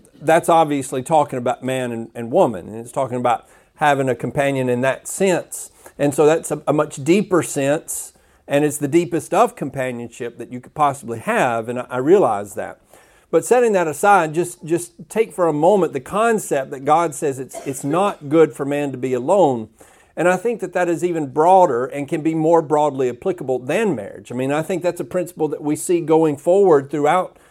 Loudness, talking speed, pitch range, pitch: -19 LUFS, 205 wpm, 135-175 Hz, 155 Hz